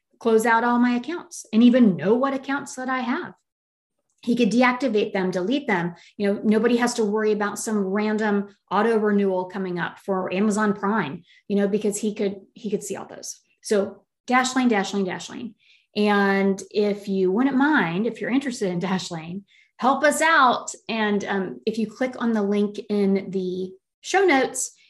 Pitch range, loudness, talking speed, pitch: 195-240 Hz, -22 LUFS, 180 wpm, 210 Hz